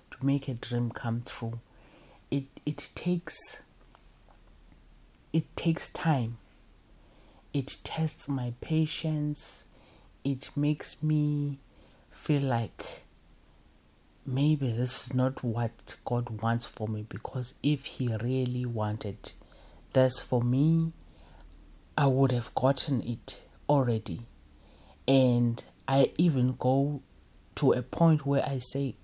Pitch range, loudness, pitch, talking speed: 115-140 Hz, -27 LUFS, 130 Hz, 110 wpm